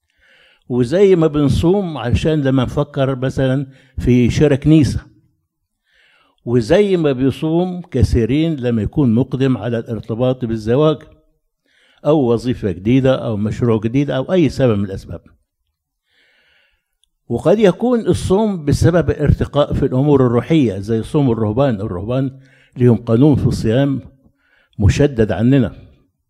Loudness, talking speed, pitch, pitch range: -16 LUFS, 110 wpm, 130 Hz, 115-150 Hz